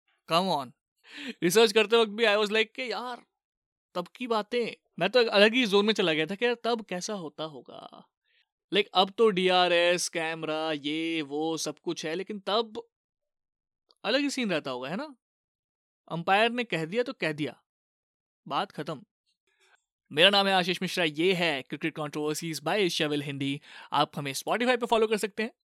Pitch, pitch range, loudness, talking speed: 195 Hz, 160-235 Hz, -27 LUFS, 180 wpm